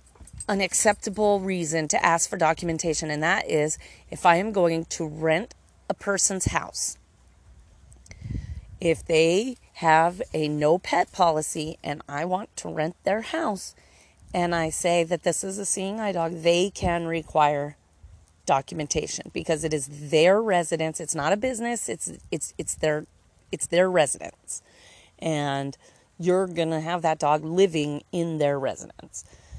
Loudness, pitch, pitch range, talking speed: -25 LUFS, 165 Hz, 150-180 Hz, 150 wpm